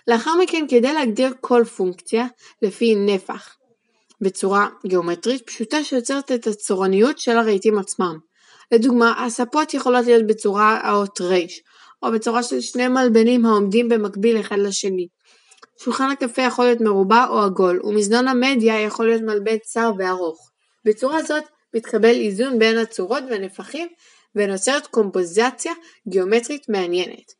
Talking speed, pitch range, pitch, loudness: 125 wpm, 205-250 Hz, 225 Hz, -19 LUFS